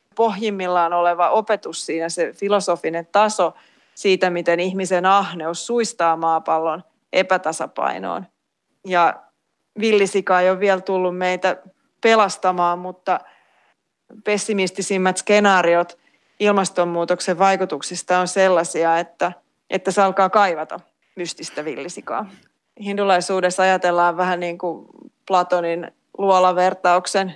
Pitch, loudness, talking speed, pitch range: 185 Hz, -19 LUFS, 95 wpm, 175-195 Hz